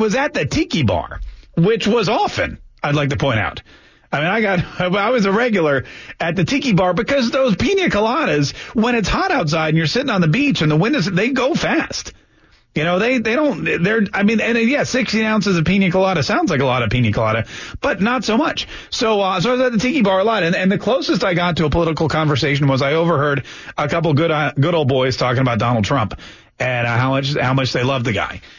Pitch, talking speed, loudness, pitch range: 165 Hz, 250 wpm, -17 LUFS, 135-220 Hz